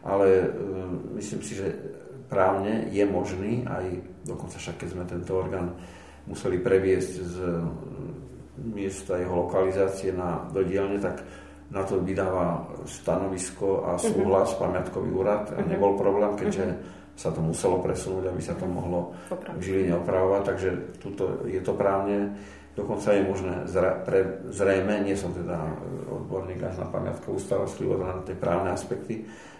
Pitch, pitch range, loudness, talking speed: 95 Hz, 90-100 Hz, -28 LUFS, 140 wpm